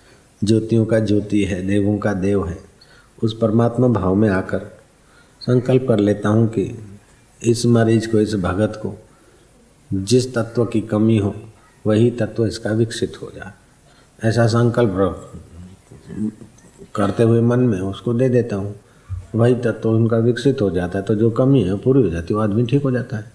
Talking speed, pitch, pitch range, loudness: 170 wpm, 110 Hz, 100-120 Hz, -18 LUFS